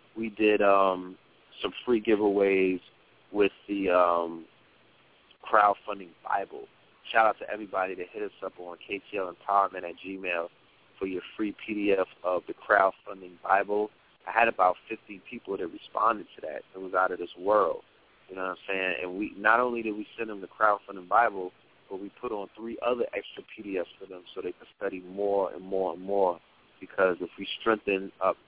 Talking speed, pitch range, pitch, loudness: 185 wpm, 95-105 Hz, 100 Hz, -28 LUFS